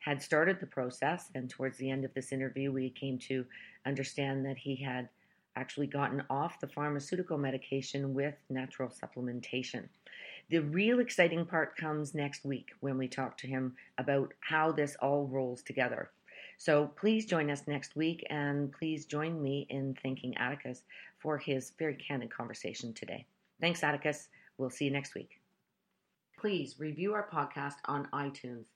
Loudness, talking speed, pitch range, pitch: -36 LUFS, 160 wpm, 130-155 Hz, 140 Hz